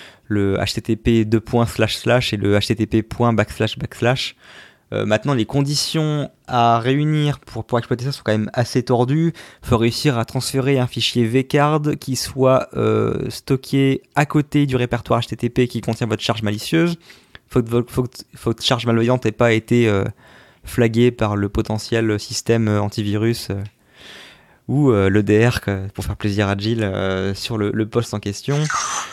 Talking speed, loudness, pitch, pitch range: 165 wpm, -19 LUFS, 115 Hz, 105-130 Hz